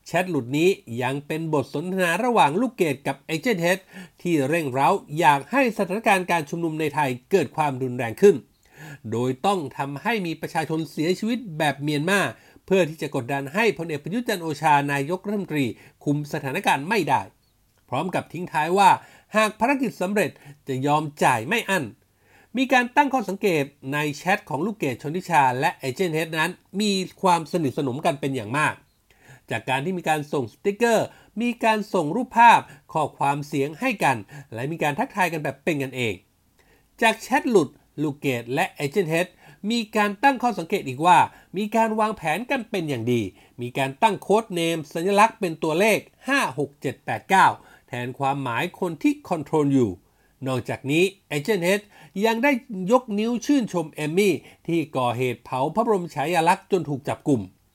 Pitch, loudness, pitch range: 165 Hz, -23 LUFS, 140-205 Hz